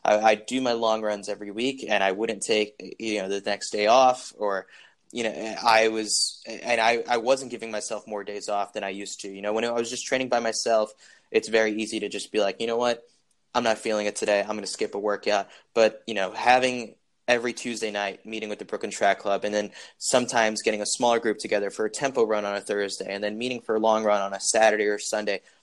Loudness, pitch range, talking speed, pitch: -25 LUFS, 105-115 Hz, 245 wpm, 110 Hz